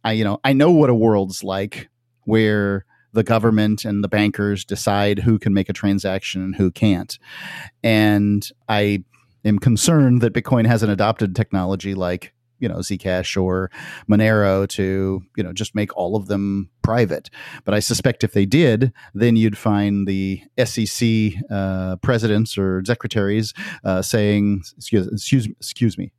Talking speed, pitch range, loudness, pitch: 160 wpm, 95-115 Hz, -19 LUFS, 105 Hz